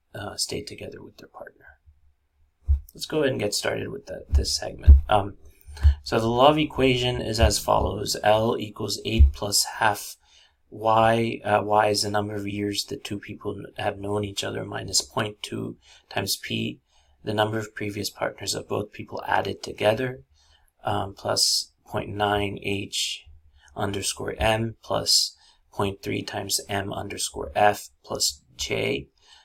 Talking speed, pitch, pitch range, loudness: 145 wpm, 100 Hz, 80-105 Hz, -25 LUFS